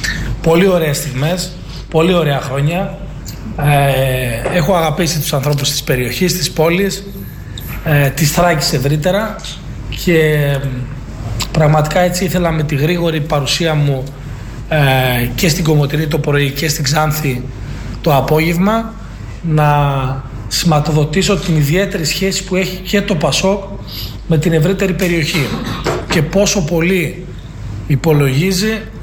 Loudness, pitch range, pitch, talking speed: -14 LUFS, 140-175 Hz, 155 Hz, 120 wpm